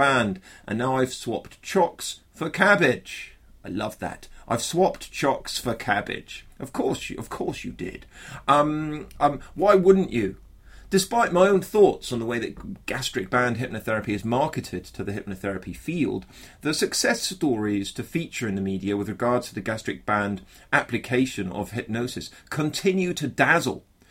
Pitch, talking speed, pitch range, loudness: 120 Hz, 160 wpm, 100-145 Hz, -25 LUFS